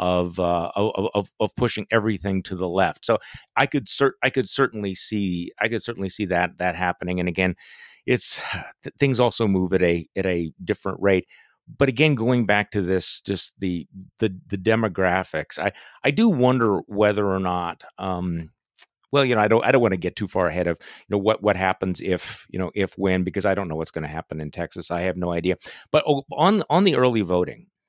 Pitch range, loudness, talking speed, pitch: 90-115 Hz, -23 LUFS, 215 wpm, 95 Hz